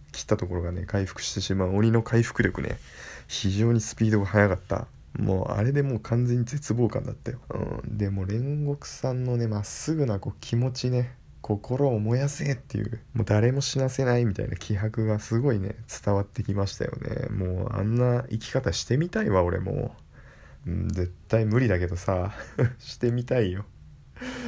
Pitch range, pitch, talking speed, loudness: 100-125 Hz, 115 Hz, 350 characters per minute, -27 LUFS